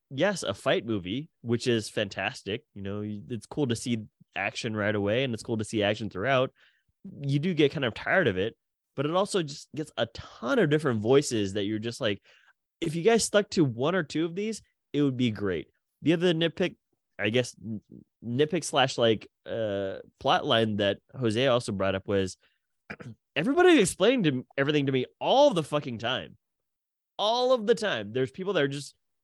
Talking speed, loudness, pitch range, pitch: 195 wpm, -27 LUFS, 110-160 Hz, 130 Hz